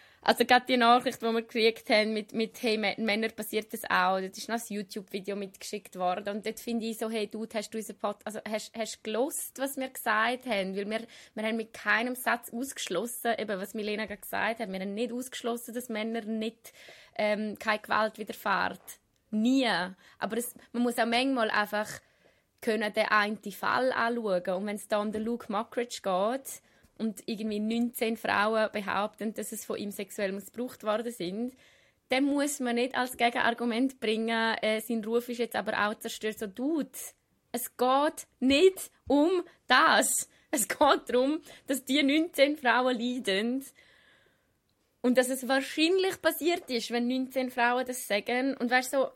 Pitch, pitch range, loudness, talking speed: 230 Hz, 215-250 Hz, -29 LUFS, 175 wpm